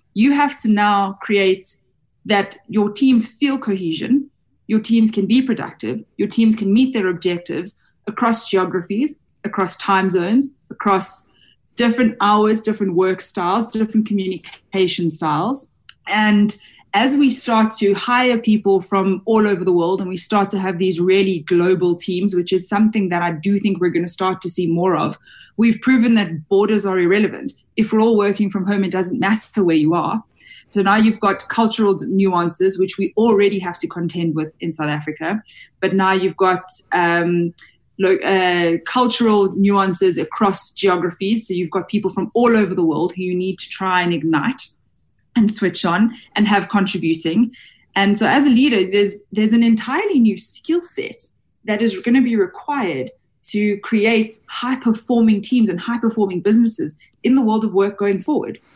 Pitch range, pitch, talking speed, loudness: 185-225 Hz, 200 Hz, 175 wpm, -18 LUFS